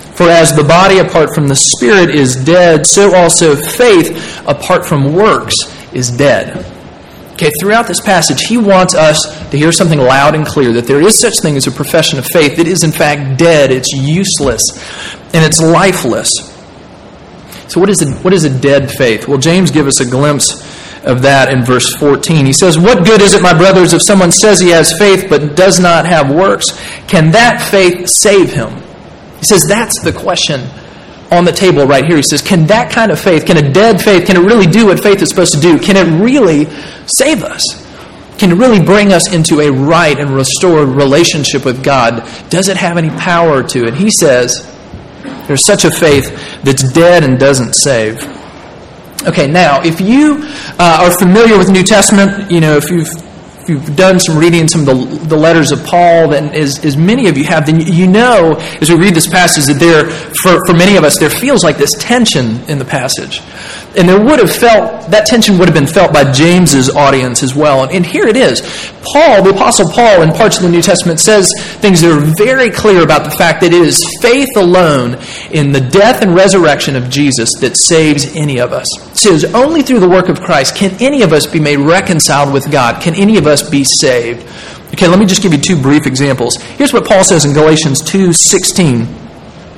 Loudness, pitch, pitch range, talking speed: -7 LUFS, 165 Hz, 145-190 Hz, 210 wpm